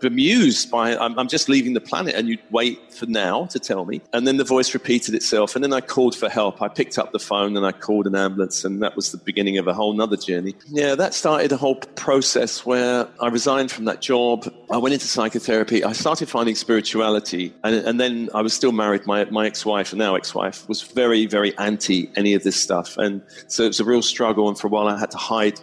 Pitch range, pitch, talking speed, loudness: 105-125 Hz, 110 Hz, 250 wpm, -20 LUFS